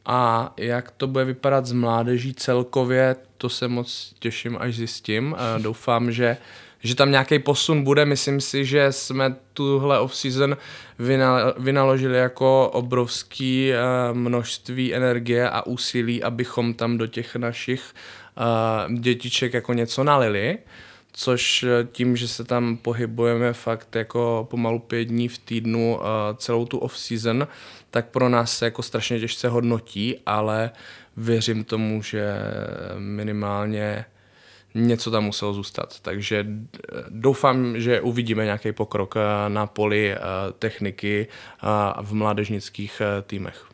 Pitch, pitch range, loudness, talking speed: 120 Hz, 110-125 Hz, -23 LUFS, 120 wpm